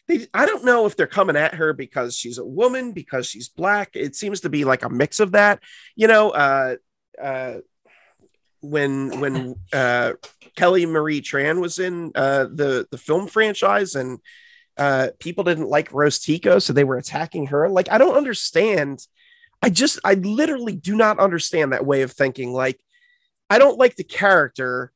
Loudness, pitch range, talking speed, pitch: -19 LUFS, 135-215 Hz, 180 wpm, 160 Hz